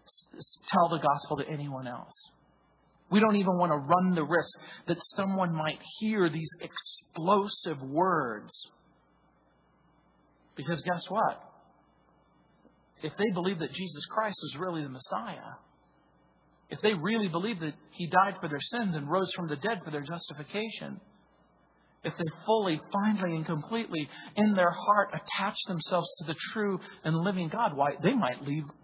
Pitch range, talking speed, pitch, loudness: 155-200 Hz, 150 wpm, 175 Hz, -31 LUFS